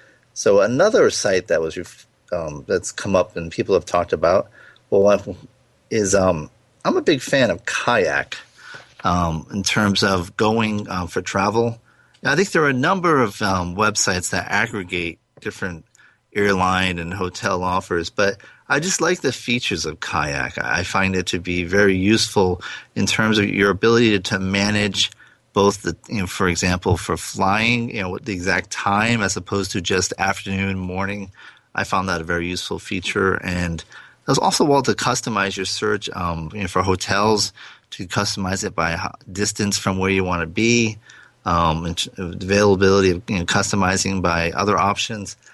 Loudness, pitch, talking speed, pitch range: -20 LUFS, 100 Hz, 175 wpm, 95-110 Hz